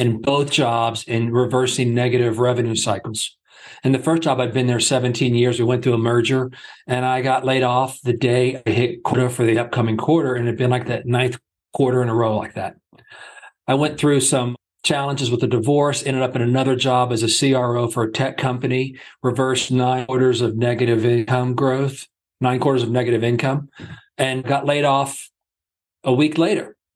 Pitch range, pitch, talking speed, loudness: 120-130 Hz, 125 Hz, 195 wpm, -19 LUFS